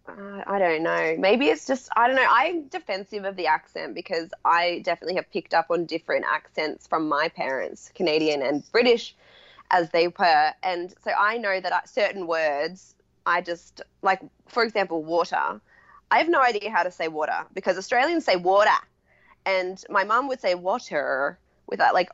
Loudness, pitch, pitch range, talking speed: -24 LUFS, 190 Hz, 170-230 Hz, 180 wpm